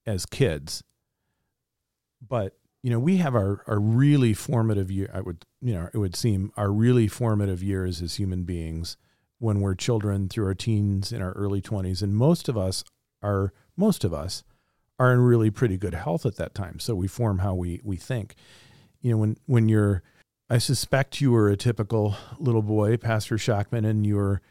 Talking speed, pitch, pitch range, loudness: 190 wpm, 105 Hz, 95-120 Hz, -25 LUFS